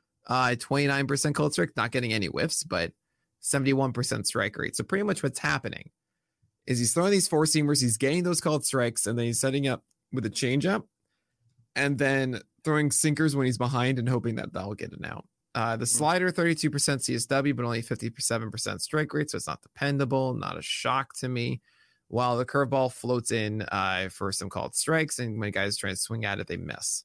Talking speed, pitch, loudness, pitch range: 200 wpm, 125 Hz, -27 LUFS, 115-145 Hz